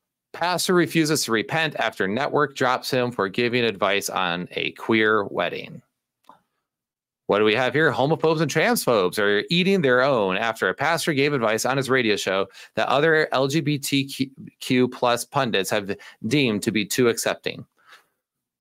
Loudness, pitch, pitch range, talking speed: -22 LUFS, 130 Hz, 110-155 Hz, 150 wpm